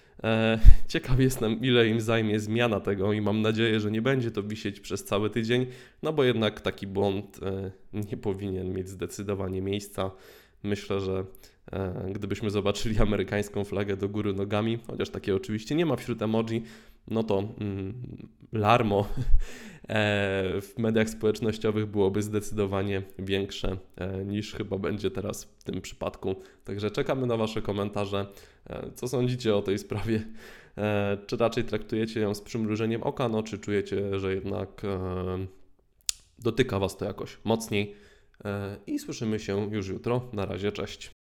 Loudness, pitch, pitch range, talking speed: -29 LUFS, 105 Hz, 100-110 Hz, 140 wpm